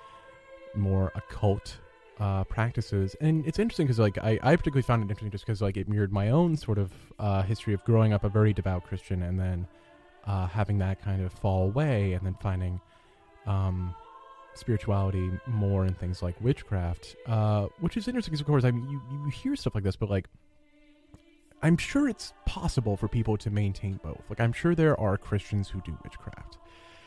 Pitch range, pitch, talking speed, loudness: 95-135 Hz, 105 Hz, 195 wpm, -29 LUFS